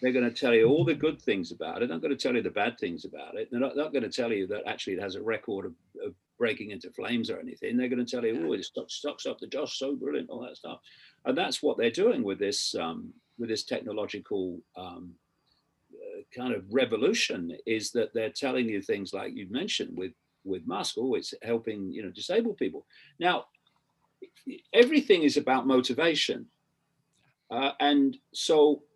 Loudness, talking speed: -29 LUFS, 210 wpm